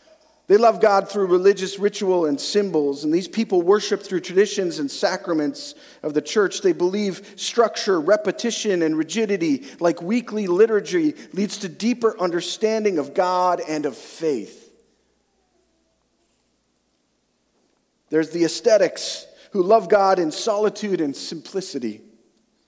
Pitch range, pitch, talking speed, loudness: 175-220 Hz, 195 Hz, 125 wpm, -21 LUFS